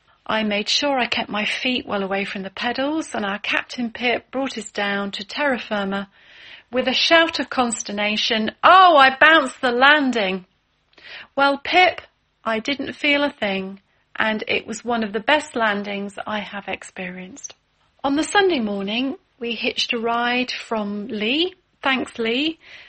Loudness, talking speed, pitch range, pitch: -20 LUFS, 165 wpm, 210-280 Hz, 235 Hz